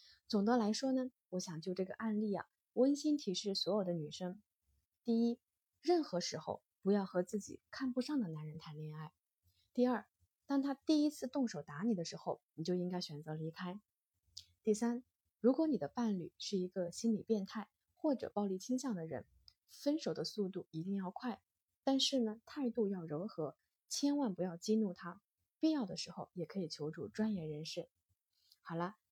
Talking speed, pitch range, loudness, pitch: 260 characters per minute, 170-245 Hz, -39 LUFS, 195 Hz